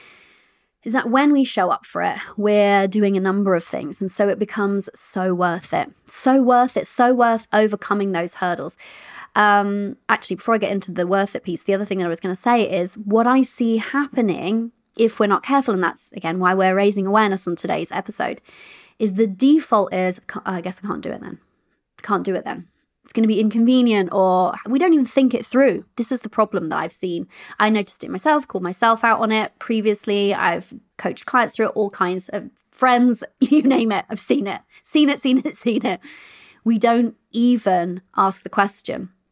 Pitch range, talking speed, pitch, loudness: 195-240 Hz, 210 wpm, 215 Hz, -19 LUFS